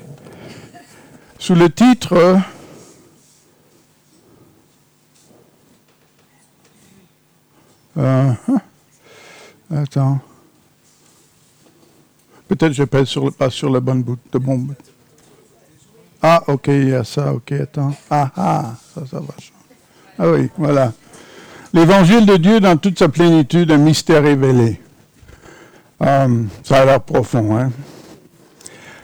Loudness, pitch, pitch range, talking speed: -14 LUFS, 145 Hz, 135-170 Hz, 100 wpm